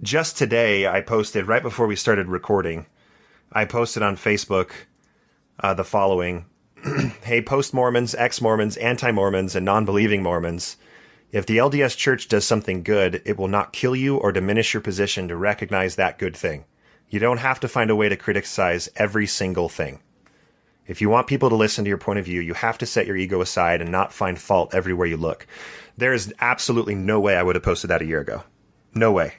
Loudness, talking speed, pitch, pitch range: -22 LUFS, 200 wpm, 105 Hz, 95-115 Hz